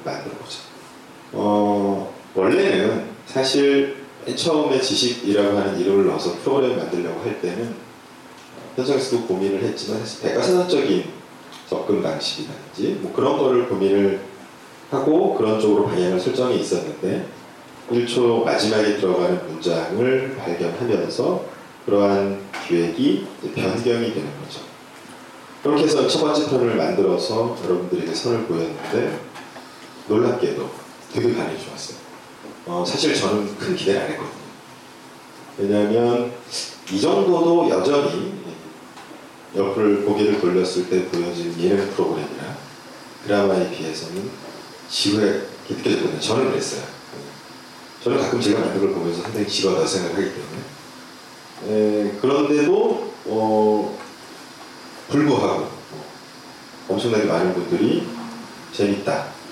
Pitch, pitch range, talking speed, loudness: 105 Hz, 90-120 Hz, 275 characters per minute, -21 LUFS